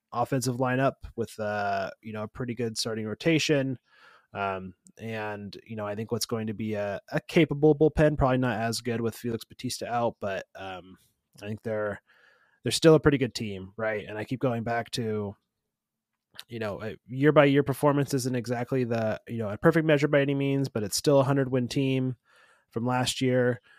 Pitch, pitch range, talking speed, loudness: 120 Hz, 110-135 Hz, 195 wpm, -27 LUFS